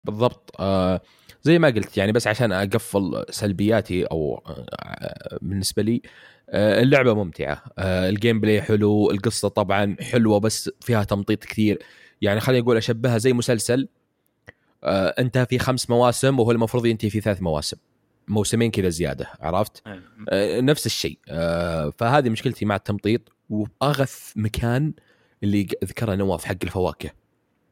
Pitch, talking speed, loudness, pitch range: 110 Hz, 125 wpm, -22 LUFS, 100-120 Hz